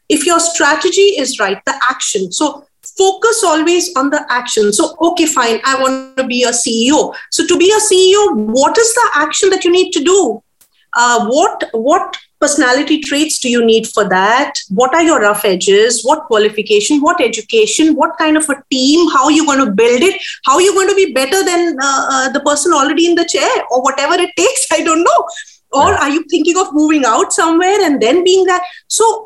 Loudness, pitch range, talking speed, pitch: -11 LUFS, 265-360 Hz, 210 wpm, 310 Hz